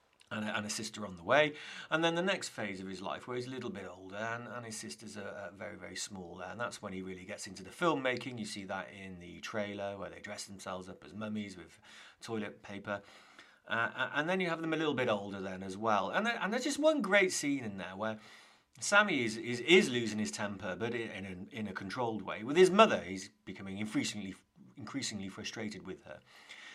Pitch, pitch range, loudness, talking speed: 105 Hz, 95-125 Hz, -34 LUFS, 235 wpm